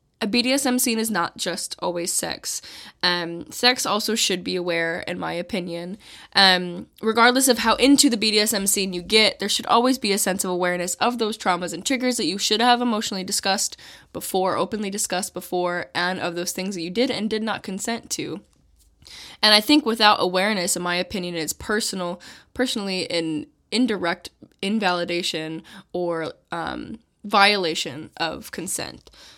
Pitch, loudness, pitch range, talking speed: 195 Hz, -21 LUFS, 175-225 Hz, 165 wpm